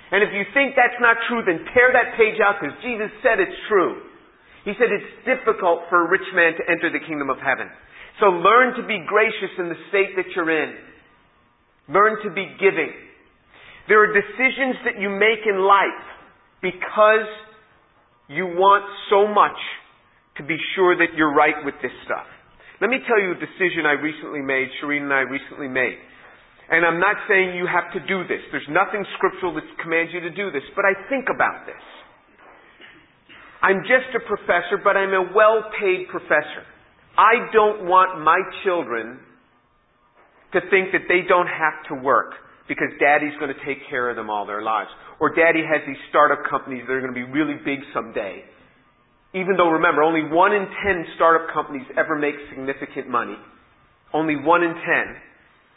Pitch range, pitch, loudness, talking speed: 150-205 Hz, 180 Hz, -20 LUFS, 180 wpm